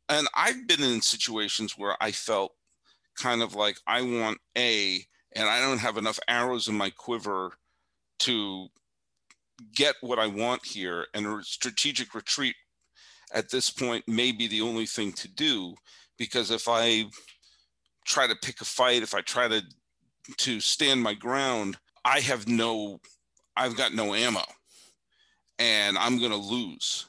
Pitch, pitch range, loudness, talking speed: 115 Hz, 105-120 Hz, -27 LUFS, 155 wpm